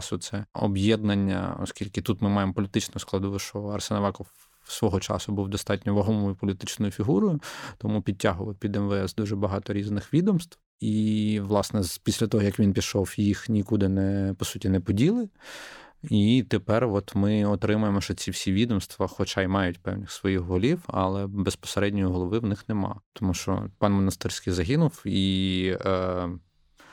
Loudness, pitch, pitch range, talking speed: -26 LUFS, 100 Hz, 95-110 Hz, 145 wpm